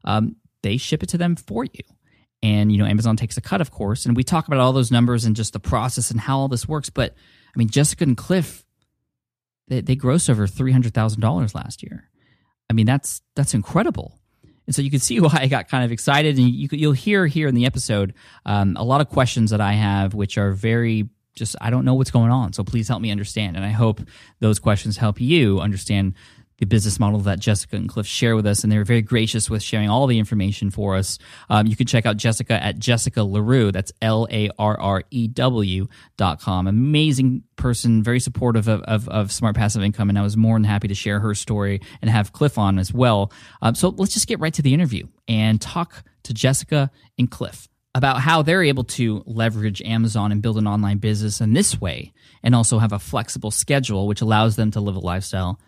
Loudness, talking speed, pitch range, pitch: -20 LUFS, 220 wpm, 105-130 Hz, 115 Hz